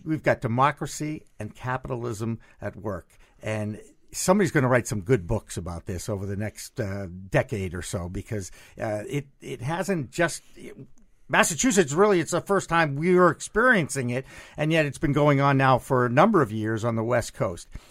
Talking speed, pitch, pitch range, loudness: 190 wpm, 130 Hz, 105-155 Hz, -25 LUFS